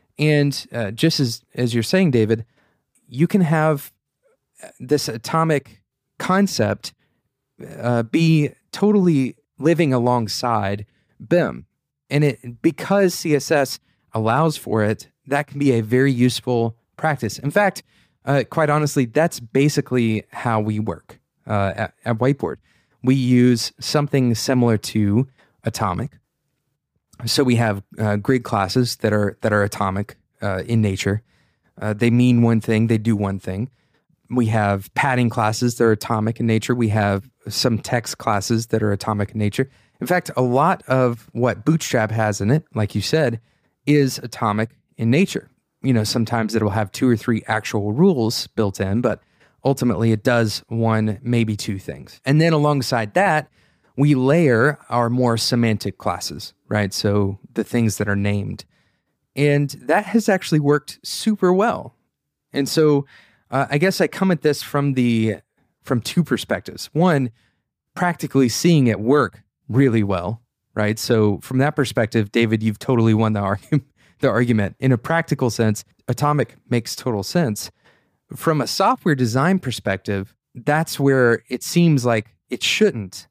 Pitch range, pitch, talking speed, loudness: 110-145 Hz, 120 Hz, 150 wpm, -20 LUFS